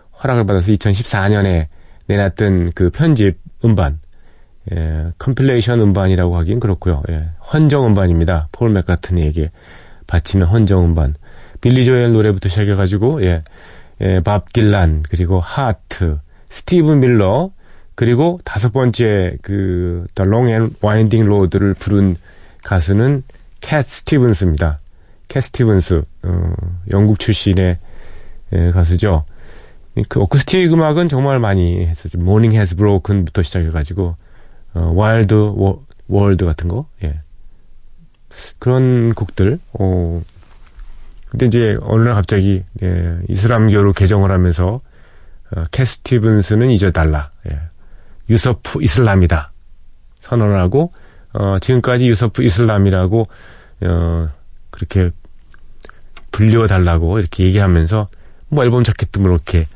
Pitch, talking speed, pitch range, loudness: 95 Hz, 255 characters per minute, 85-110 Hz, -15 LUFS